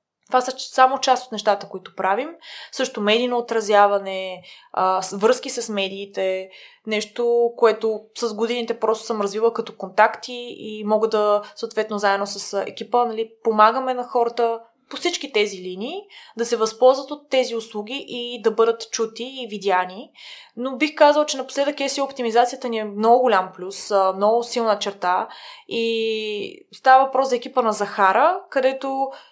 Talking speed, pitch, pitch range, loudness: 150 wpm, 230 Hz, 210-255 Hz, -21 LUFS